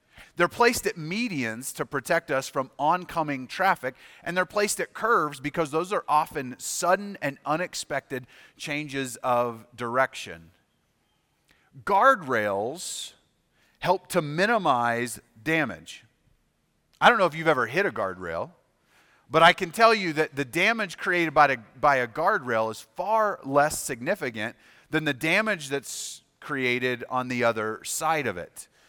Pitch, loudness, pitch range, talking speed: 150 Hz, -25 LUFS, 125-175 Hz, 140 wpm